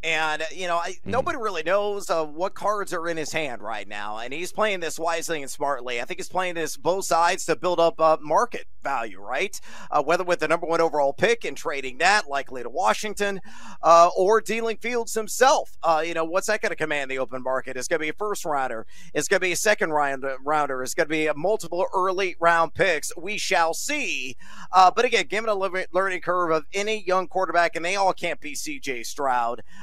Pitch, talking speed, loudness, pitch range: 175 Hz, 225 wpm, -24 LUFS, 155-200 Hz